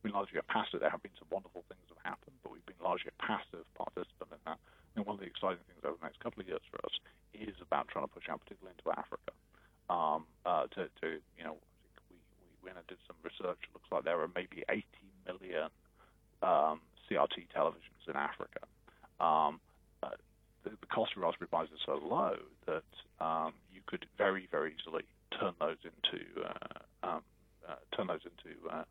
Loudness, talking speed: -39 LUFS, 215 wpm